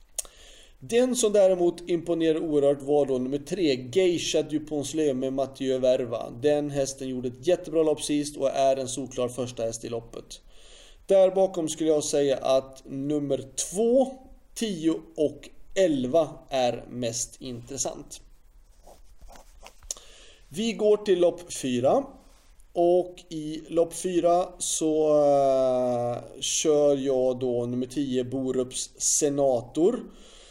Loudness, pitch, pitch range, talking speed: -26 LUFS, 145 Hz, 130-170 Hz, 120 wpm